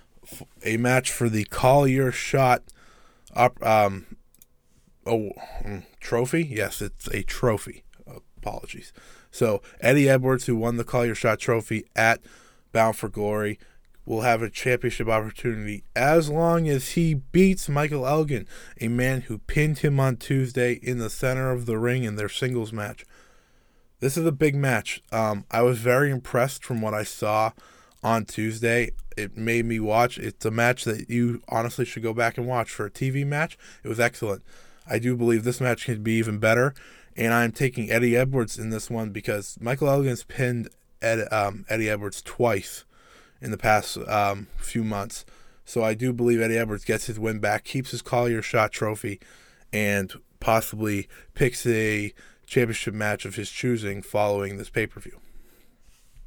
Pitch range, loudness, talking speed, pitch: 110-125 Hz, -25 LUFS, 165 wpm, 115 Hz